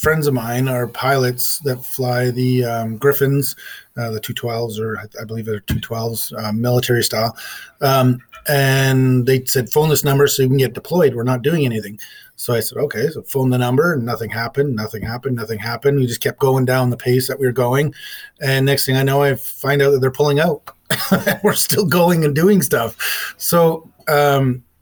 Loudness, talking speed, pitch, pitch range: -17 LUFS, 200 wpm, 130 Hz, 120-140 Hz